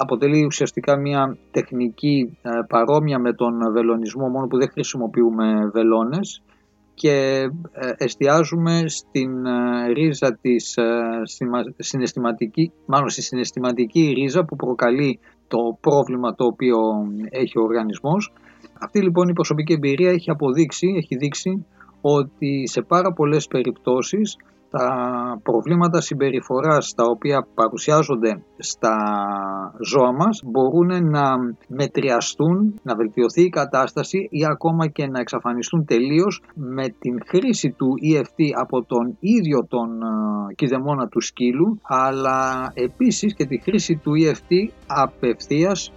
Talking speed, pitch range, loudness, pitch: 115 wpm, 120-160 Hz, -20 LUFS, 135 Hz